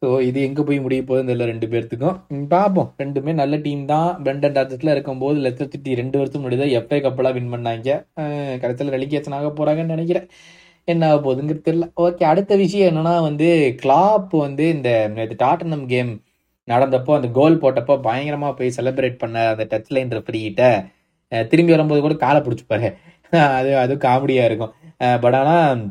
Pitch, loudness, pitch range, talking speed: 140 Hz, -18 LUFS, 125-155 Hz, 160 wpm